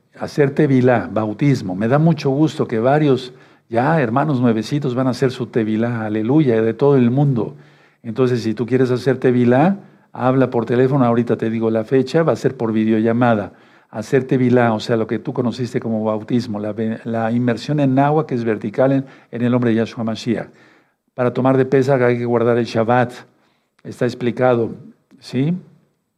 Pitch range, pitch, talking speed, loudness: 115-135 Hz, 125 Hz, 180 wpm, -17 LUFS